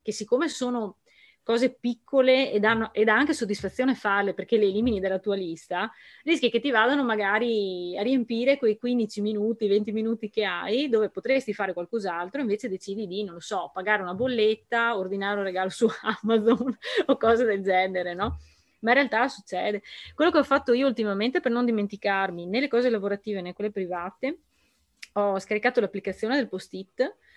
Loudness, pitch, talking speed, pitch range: -26 LUFS, 215 Hz, 170 wpm, 200-245 Hz